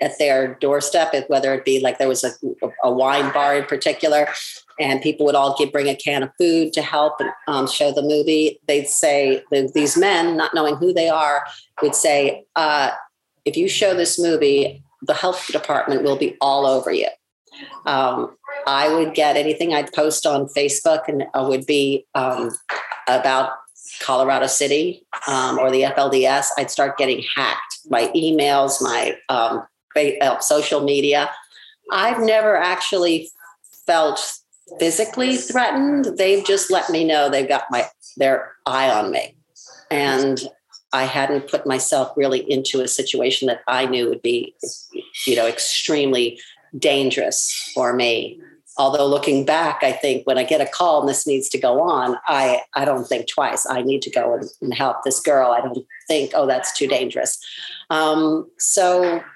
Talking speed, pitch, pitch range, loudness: 165 wpm, 145 Hz, 135-170 Hz, -19 LUFS